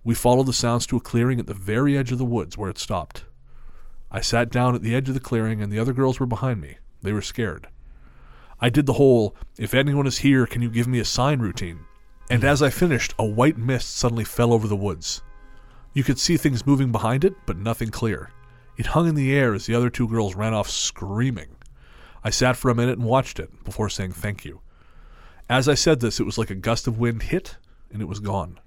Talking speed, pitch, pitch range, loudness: 240 wpm, 115 Hz, 105-130 Hz, -22 LUFS